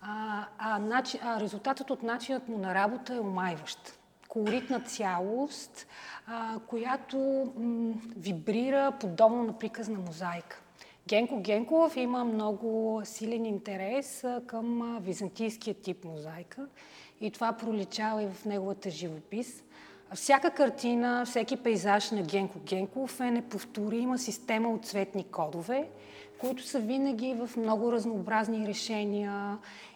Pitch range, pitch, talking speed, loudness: 205-245 Hz, 225 Hz, 115 wpm, -32 LUFS